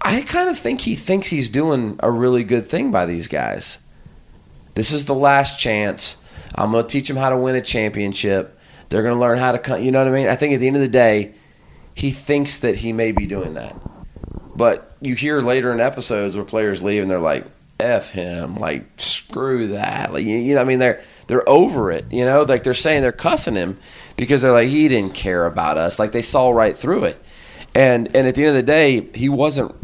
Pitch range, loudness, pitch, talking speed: 105-140 Hz, -18 LUFS, 125 Hz, 235 wpm